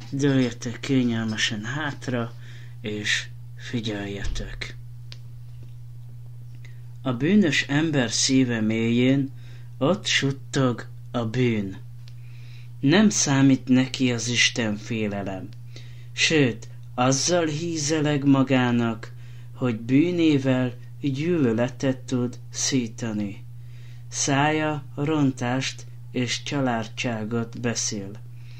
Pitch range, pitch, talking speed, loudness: 120-130 Hz, 120 Hz, 70 wpm, -24 LUFS